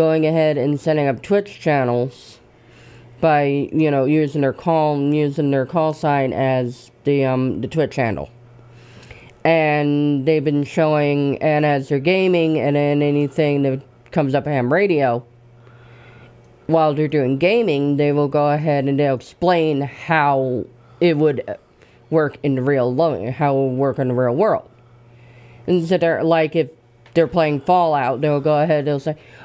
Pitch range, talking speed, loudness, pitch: 125-155 Hz, 160 wpm, -18 LUFS, 145 Hz